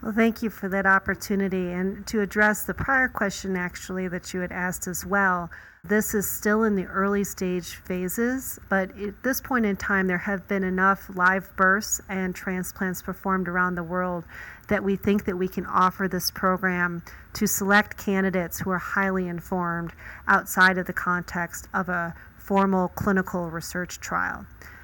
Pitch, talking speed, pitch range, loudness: 190 Hz, 170 wpm, 180-200 Hz, -25 LUFS